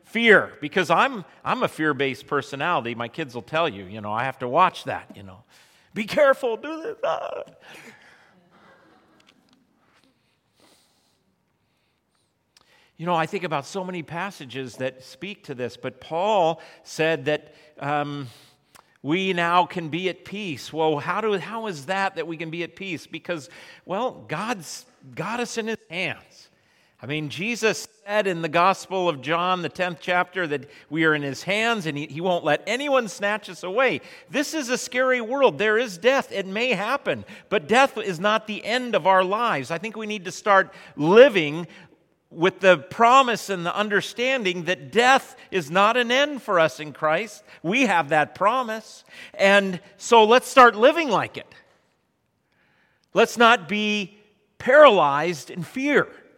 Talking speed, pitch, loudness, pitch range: 165 wpm, 185 Hz, -22 LUFS, 160-220 Hz